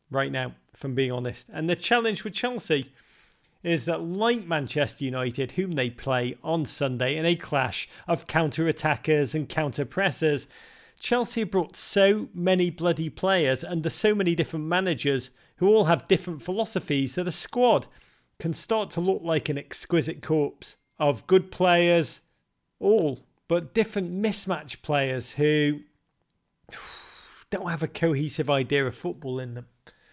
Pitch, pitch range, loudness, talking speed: 165 Hz, 140-180 Hz, -26 LUFS, 145 wpm